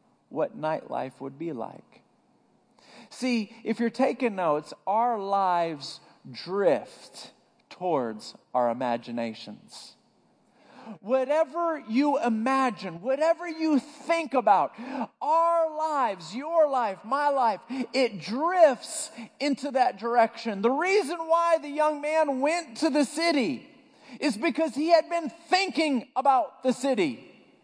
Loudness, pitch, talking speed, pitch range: -26 LUFS, 270 Hz, 115 wpm, 230-315 Hz